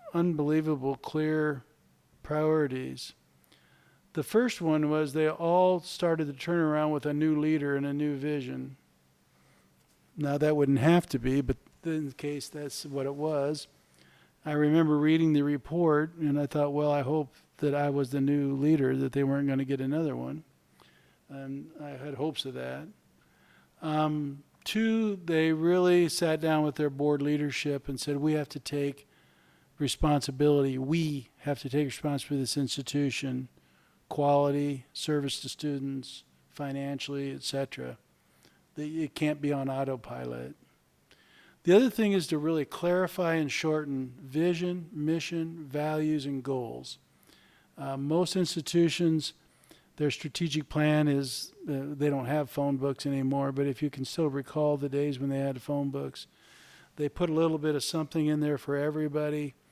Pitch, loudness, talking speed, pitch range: 145 Hz, -30 LUFS, 155 wpm, 135-155 Hz